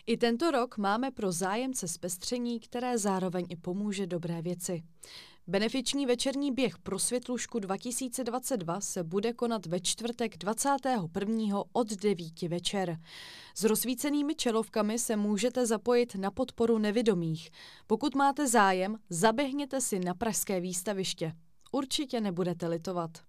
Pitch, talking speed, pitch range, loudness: 215 Hz, 125 wpm, 185-245 Hz, -31 LUFS